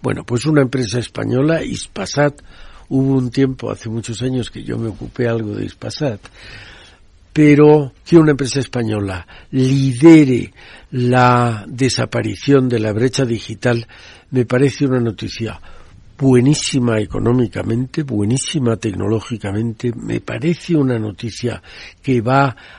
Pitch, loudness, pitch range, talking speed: 120 Hz, -16 LUFS, 110-135 Hz, 120 wpm